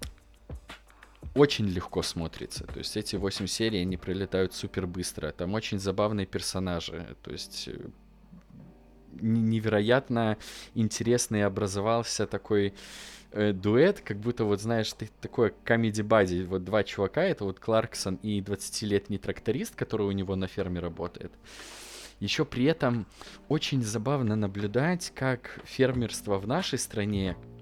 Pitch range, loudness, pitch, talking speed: 95-115 Hz, -29 LUFS, 105 Hz, 125 wpm